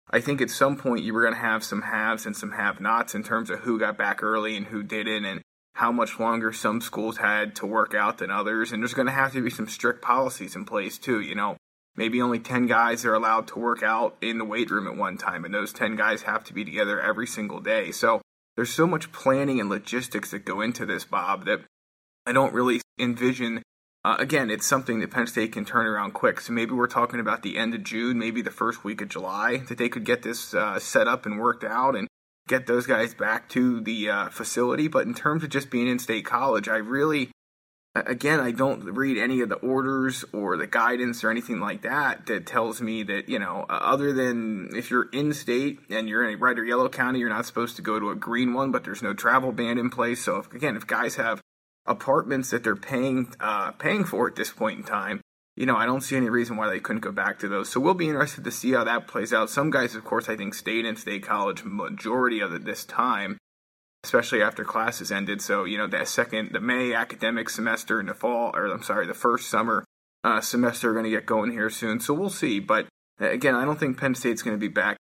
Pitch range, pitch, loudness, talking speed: 110-130 Hz, 120 Hz, -26 LUFS, 245 wpm